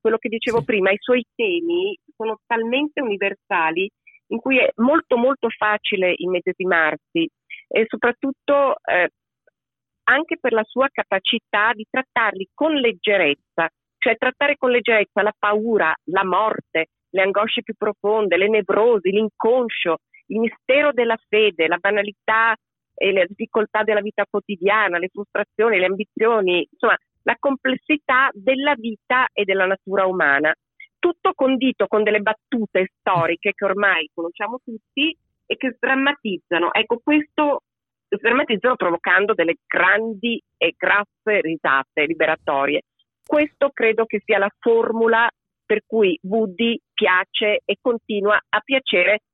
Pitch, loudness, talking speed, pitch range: 220 Hz, -20 LUFS, 130 wpm, 200-255 Hz